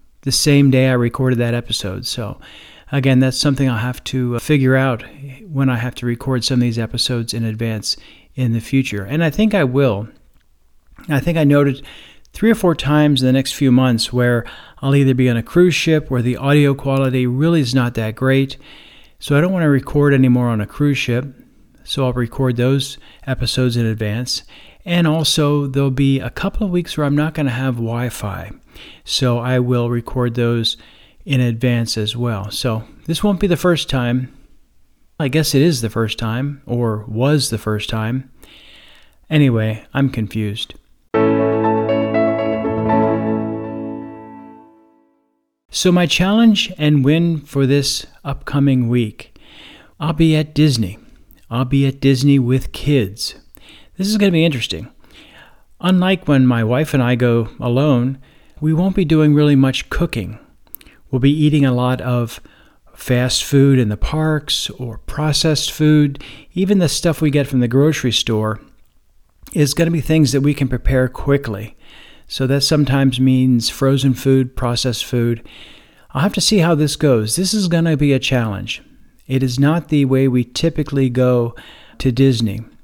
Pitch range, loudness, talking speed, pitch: 120-150 Hz, -17 LUFS, 170 wpm, 130 Hz